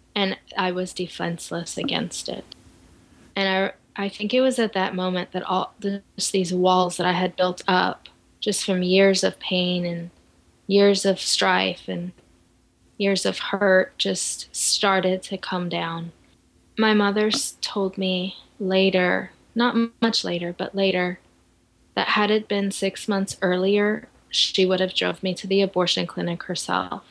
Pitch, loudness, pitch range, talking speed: 185 Hz, -23 LUFS, 175-195 Hz, 155 wpm